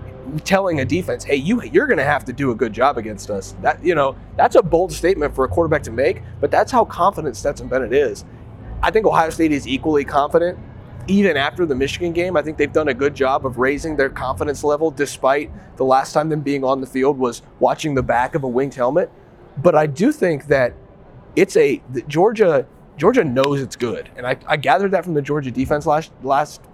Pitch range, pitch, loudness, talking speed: 130-165 Hz, 145 Hz, -18 LUFS, 225 wpm